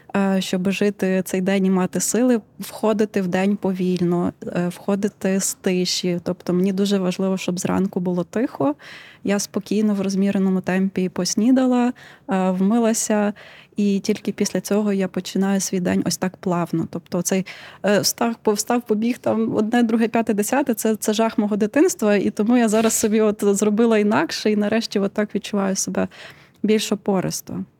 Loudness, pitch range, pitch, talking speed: -21 LUFS, 190-220 Hz, 205 Hz, 150 wpm